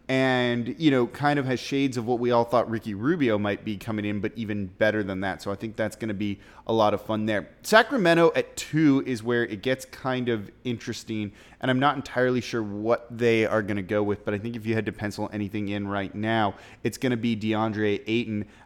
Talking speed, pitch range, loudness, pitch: 240 wpm, 105-125 Hz, -26 LUFS, 110 Hz